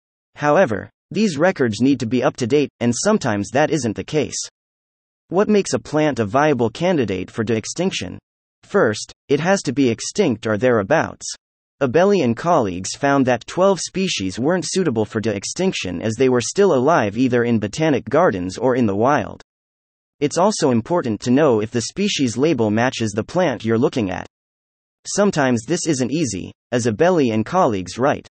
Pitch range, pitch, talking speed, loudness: 110-160 Hz, 130 Hz, 175 wpm, -19 LUFS